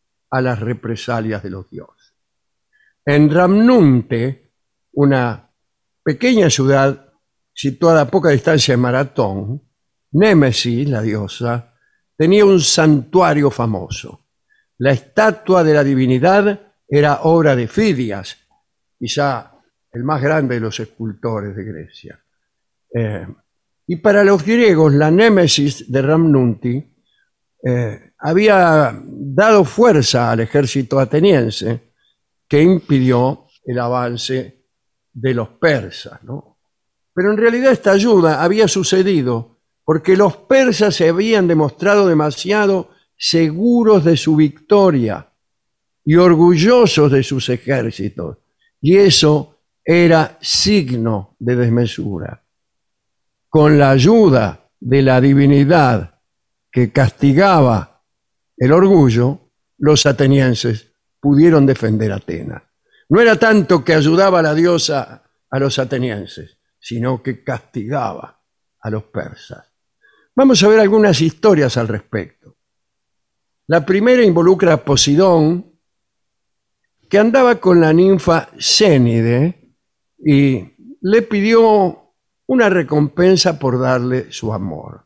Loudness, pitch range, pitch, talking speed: -14 LUFS, 120-180 Hz, 140 Hz, 110 wpm